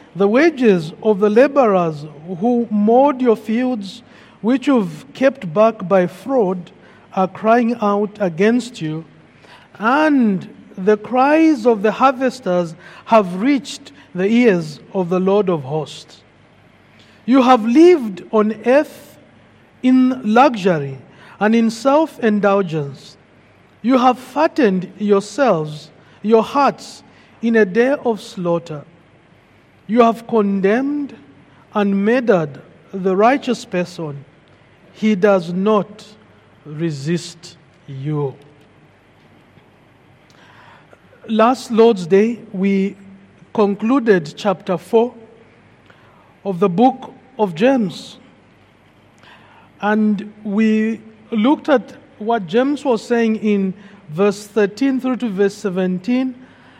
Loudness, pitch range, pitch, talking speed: -16 LUFS, 180-240 Hz, 210 Hz, 100 wpm